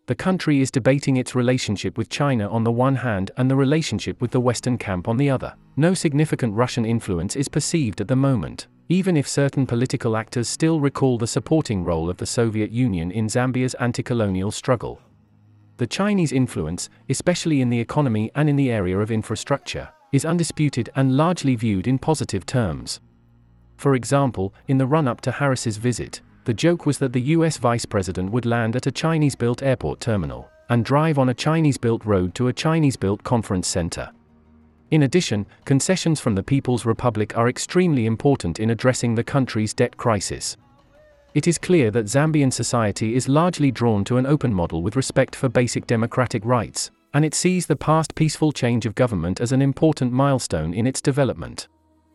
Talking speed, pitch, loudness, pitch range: 185 wpm, 125 Hz, -21 LUFS, 110-140 Hz